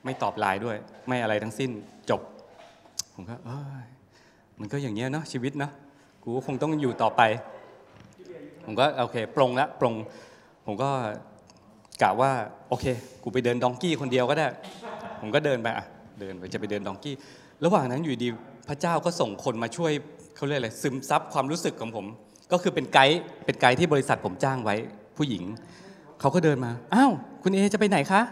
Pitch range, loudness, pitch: 115-150 Hz, -27 LUFS, 130 Hz